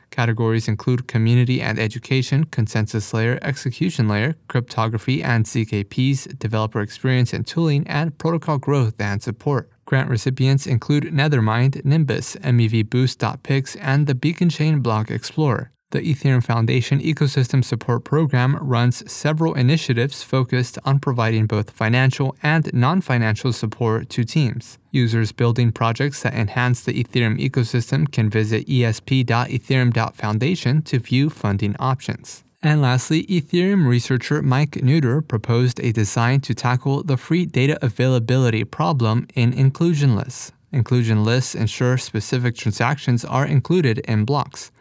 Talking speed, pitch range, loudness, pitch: 125 wpm, 115-140 Hz, -20 LUFS, 125 Hz